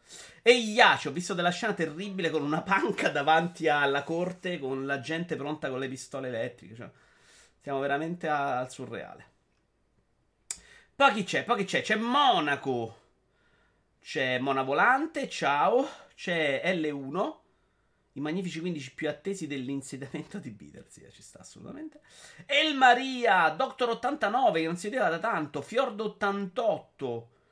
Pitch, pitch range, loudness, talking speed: 165 Hz, 140-215 Hz, -28 LUFS, 140 wpm